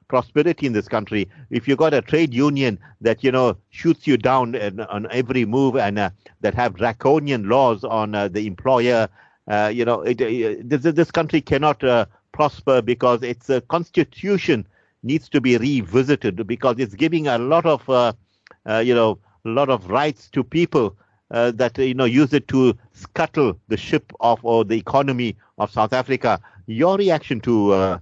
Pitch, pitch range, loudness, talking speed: 125 Hz, 110-140 Hz, -20 LUFS, 180 wpm